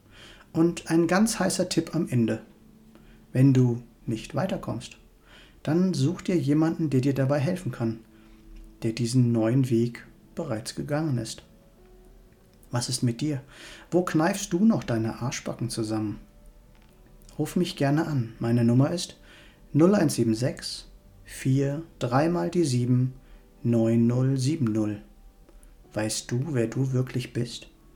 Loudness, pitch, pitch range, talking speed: -26 LUFS, 125 Hz, 115-155 Hz, 125 wpm